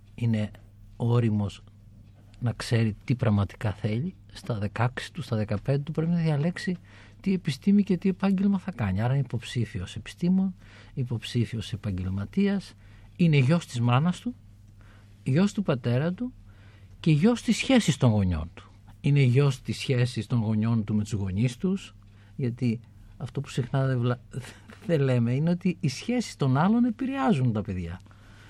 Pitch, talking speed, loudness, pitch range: 120 Hz, 155 wpm, -27 LUFS, 105-155 Hz